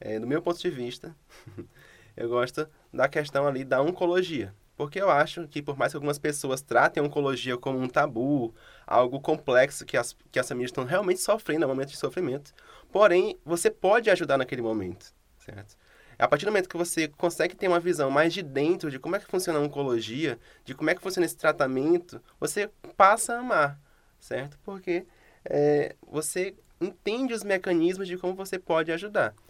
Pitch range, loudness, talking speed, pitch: 135-185 Hz, -27 LUFS, 190 wpm, 155 Hz